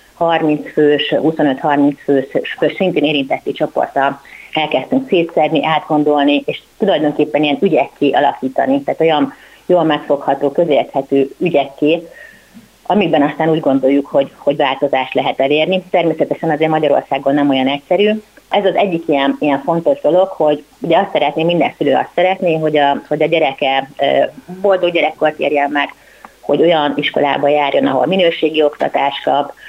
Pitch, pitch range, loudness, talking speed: 150 Hz, 140-165 Hz, -14 LUFS, 140 wpm